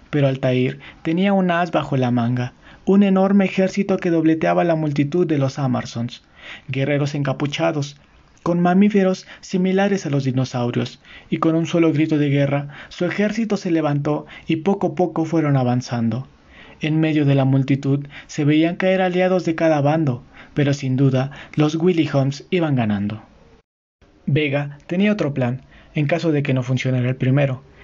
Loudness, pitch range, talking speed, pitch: -20 LUFS, 135-175 Hz, 165 wpm, 150 Hz